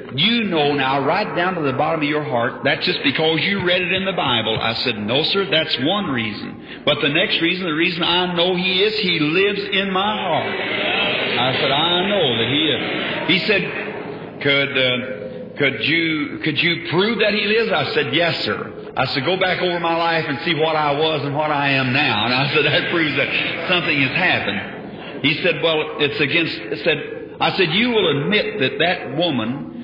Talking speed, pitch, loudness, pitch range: 210 wpm, 160 Hz, -18 LUFS, 140-180 Hz